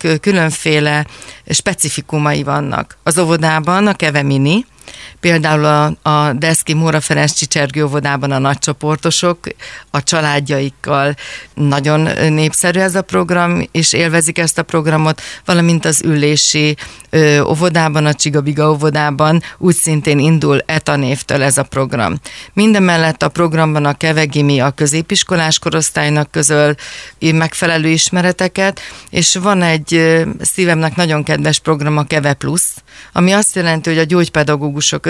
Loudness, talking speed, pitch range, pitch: -13 LUFS, 120 wpm, 150-170 Hz, 155 Hz